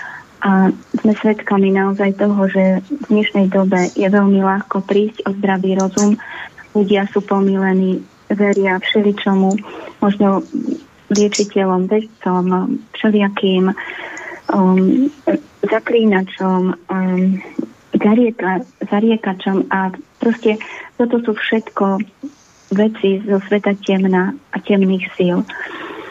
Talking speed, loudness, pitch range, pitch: 95 wpm, -16 LUFS, 190-220 Hz, 200 Hz